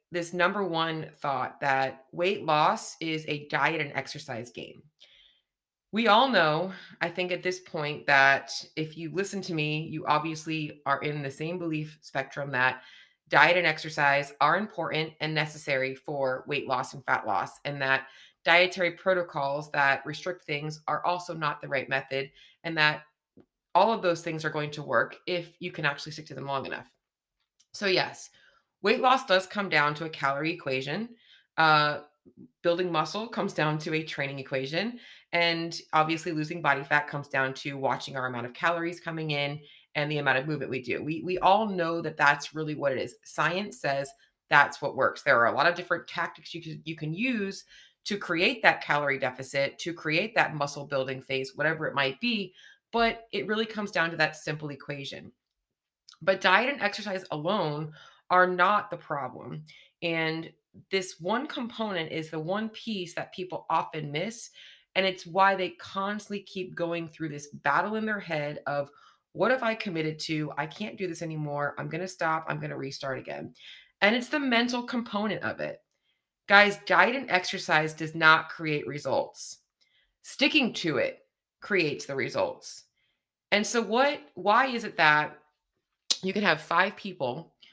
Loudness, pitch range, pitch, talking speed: -28 LUFS, 145-185 Hz, 160 Hz, 175 wpm